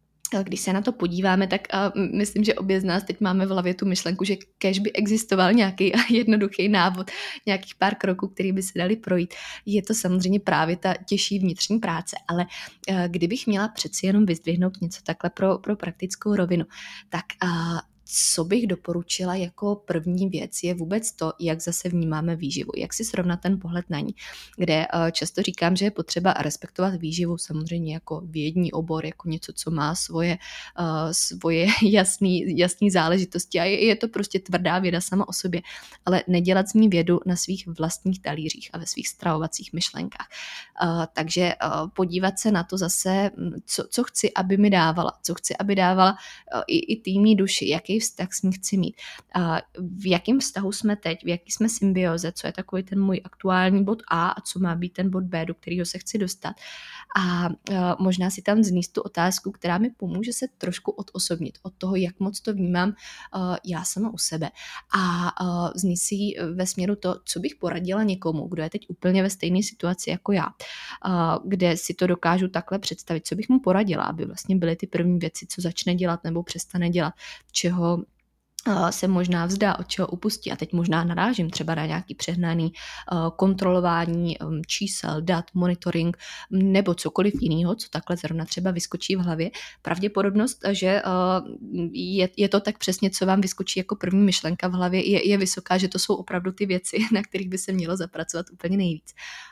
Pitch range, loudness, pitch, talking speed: 170-195 Hz, -24 LUFS, 185 Hz, 180 wpm